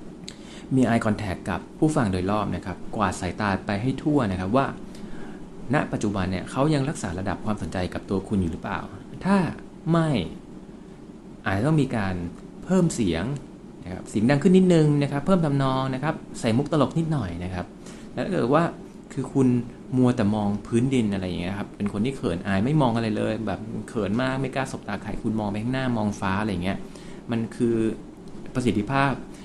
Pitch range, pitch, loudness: 100-135 Hz, 115 Hz, -25 LUFS